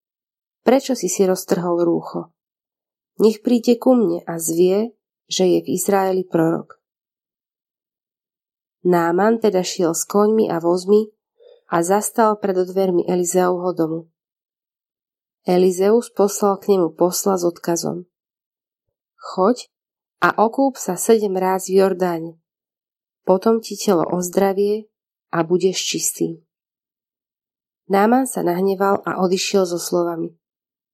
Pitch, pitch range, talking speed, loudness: 190 Hz, 175-210 Hz, 115 wpm, -19 LUFS